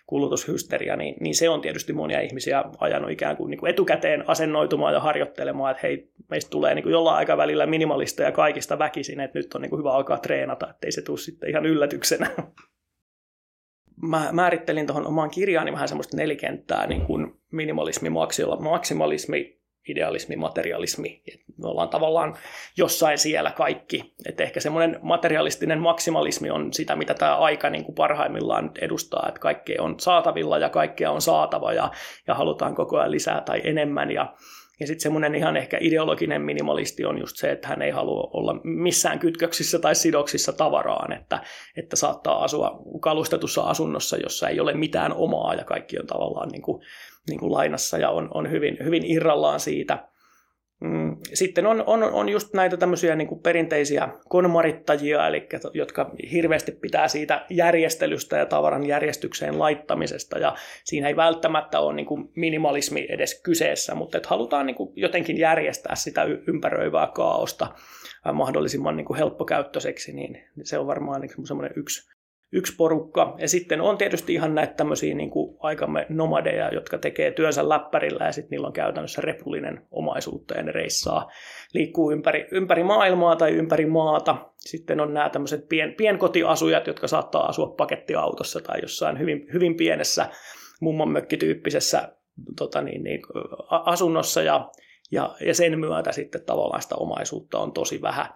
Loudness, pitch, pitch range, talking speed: -24 LUFS, 160 Hz, 150-170 Hz, 155 wpm